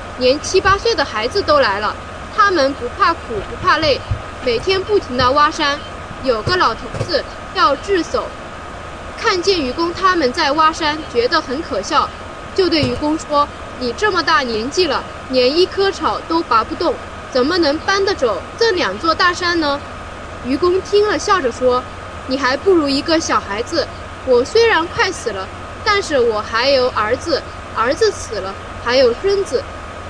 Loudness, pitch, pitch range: -16 LUFS, 335 Hz, 280-400 Hz